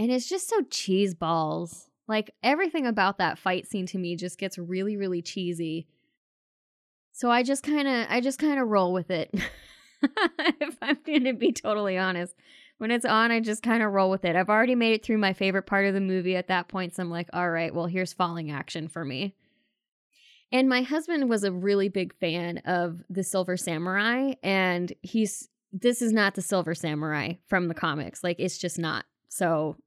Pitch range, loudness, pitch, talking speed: 175-235 Hz, -27 LUFS, 195 Hz, 205 wpm